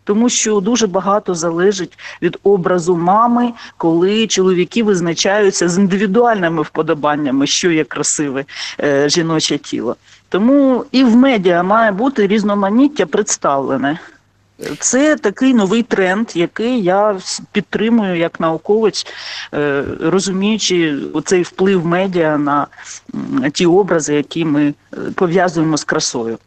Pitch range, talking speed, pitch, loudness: 165-220 Hz, 110 wpm, 190 Hz, -14 LUFS